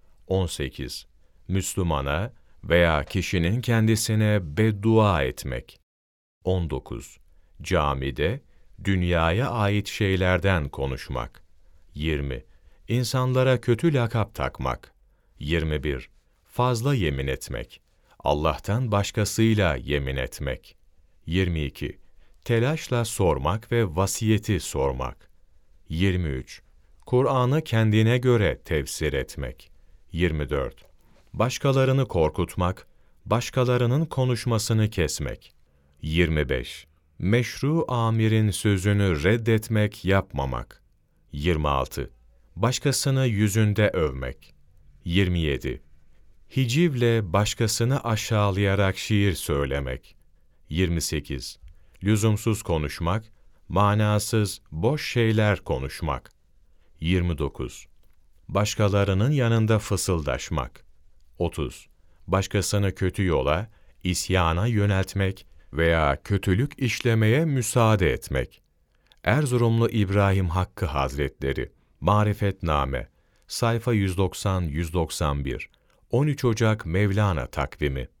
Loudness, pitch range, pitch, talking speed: -25 LUFS, 75-110 Hz, 95 Hz, 70 wpm